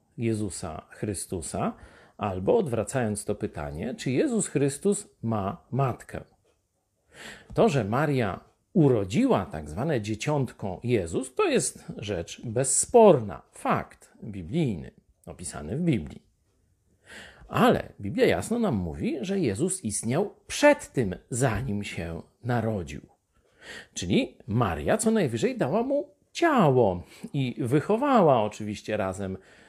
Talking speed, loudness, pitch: 105 wpm, -26 LUFS, 125 Hz